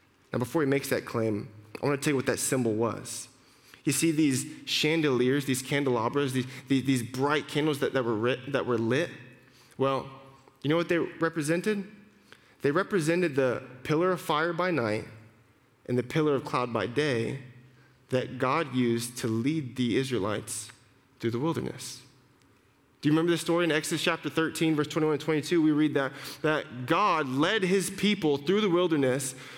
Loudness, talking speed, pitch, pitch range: -28 LUFS, 180 wpm, 135 Hz, 125-155 Hz